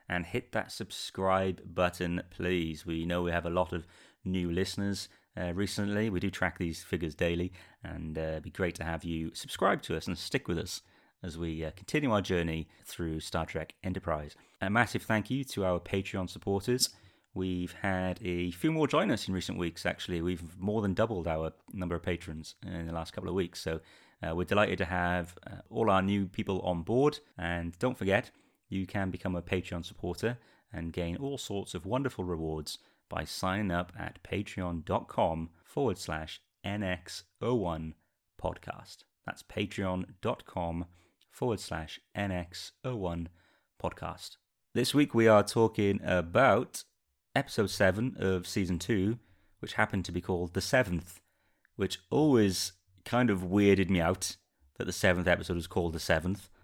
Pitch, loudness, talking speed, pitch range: 90 Hz, -32 LUFS, 165 wpm, 85-100 Hz